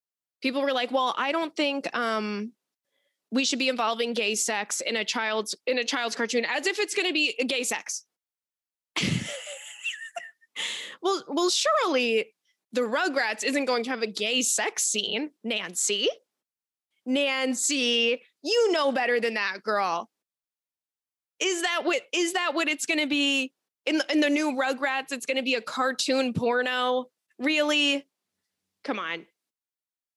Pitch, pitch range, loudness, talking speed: 265 Hz, 240-305 Hz, -26 LUFS, 145 wpm